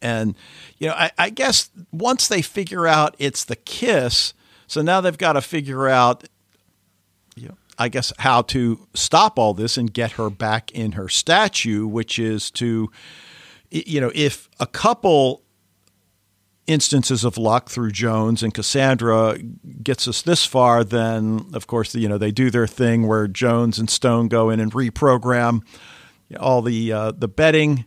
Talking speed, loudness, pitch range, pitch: 165 wpm, -19 LUFS, 110-135 Hz, 115 Hz